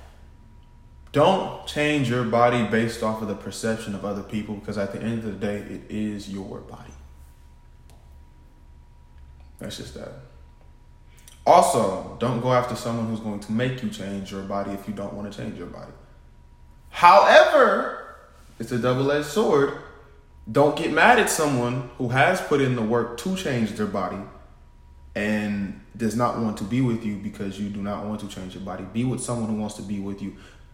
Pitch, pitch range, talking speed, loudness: 105 Hz, 70-115 Hz, 185 wpm, -23 LUFS